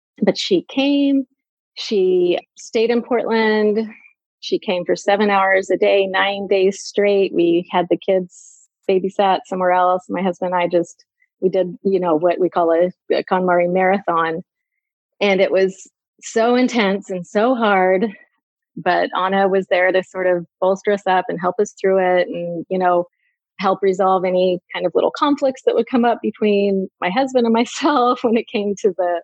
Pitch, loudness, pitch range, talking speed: 195 Hz, -18 LUFS, 185-230 Hz, 175 wpm